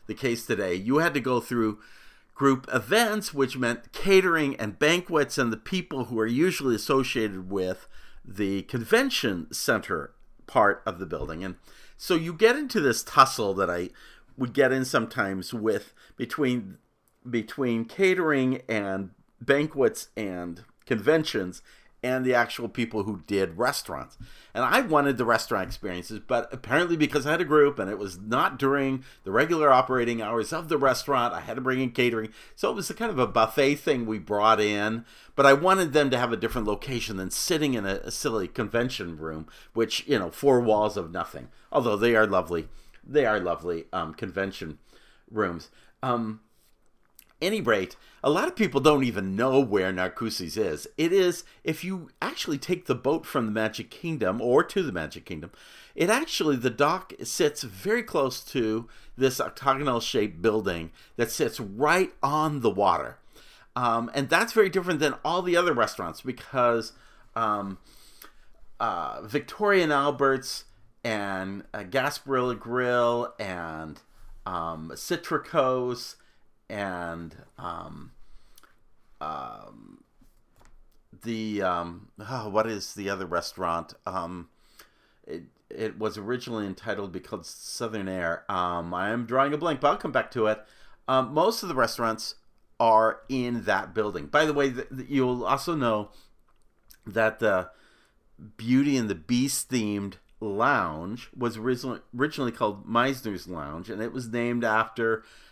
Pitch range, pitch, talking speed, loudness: 105-135 Hz, 120 Hz, 155 wpm, -26 LUFS